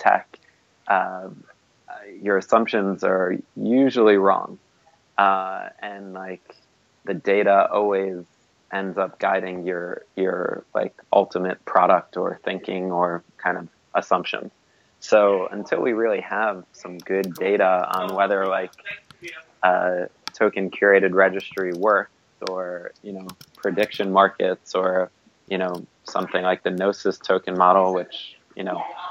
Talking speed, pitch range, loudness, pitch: 125 wpm, 90-100 Hz, -22 LUFS, 95 Hz